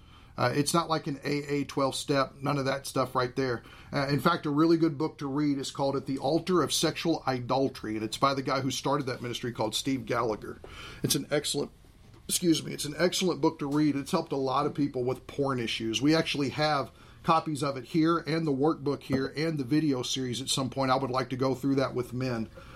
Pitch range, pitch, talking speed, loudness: 130-150 Hz, 140 Hz, 235 wpm, -29 LUFS